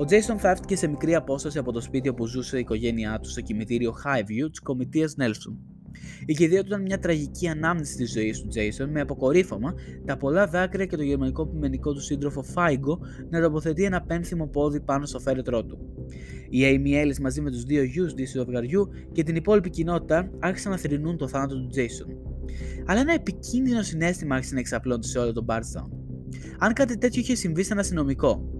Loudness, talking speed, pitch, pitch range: -26 LUFS, 195 wpm, 145 Hz, 125-175 Hz